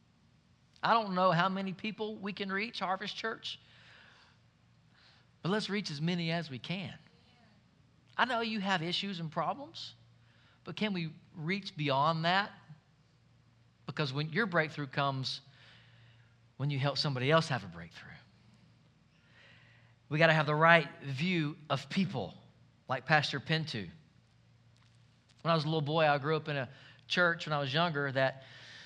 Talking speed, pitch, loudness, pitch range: 155 wpm, 155 Hz, -32 LUFS, 130-175 Hz